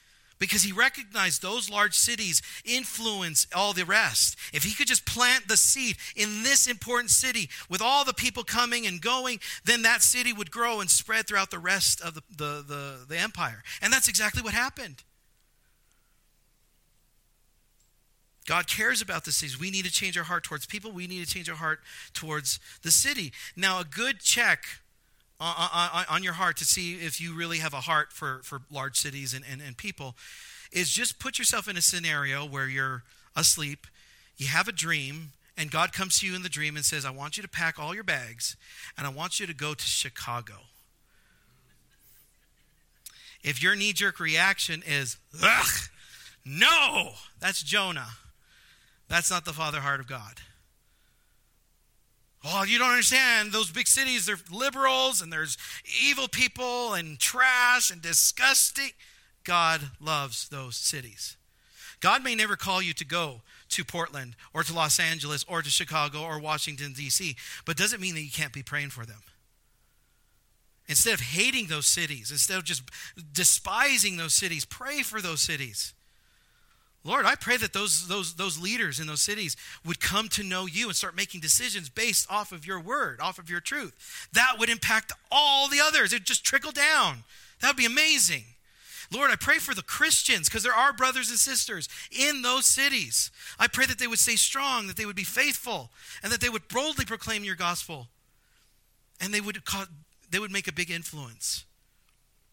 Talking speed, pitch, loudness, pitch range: 180 wpm, 175 Hz, -25 LUFS, 150-220 Hz